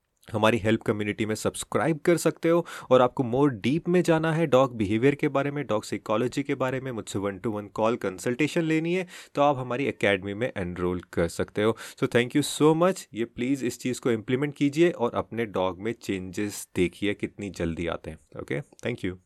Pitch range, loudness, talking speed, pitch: 105-145 Hz, -26 LUFS, 210 wpm, 120 Hz